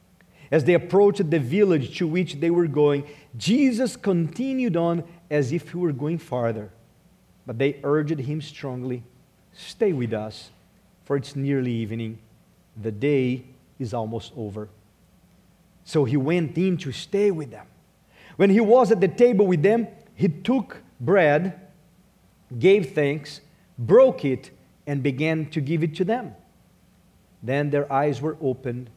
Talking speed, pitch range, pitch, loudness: 145 wpm, 130-180 Hz, 150 Hz, -23 LUFS